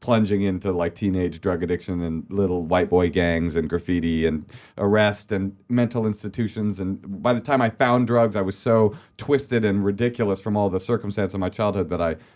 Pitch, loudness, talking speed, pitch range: 100 Hz, -23 LUFS, 195 wpm, 90-115 Hz